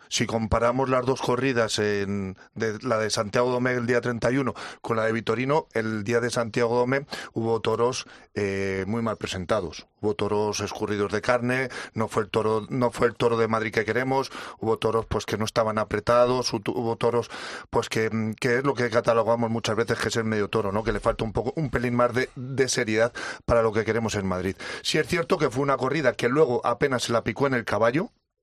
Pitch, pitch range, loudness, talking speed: 115 Hz, 110-125 Hz, -25 LUFS, 215 wpm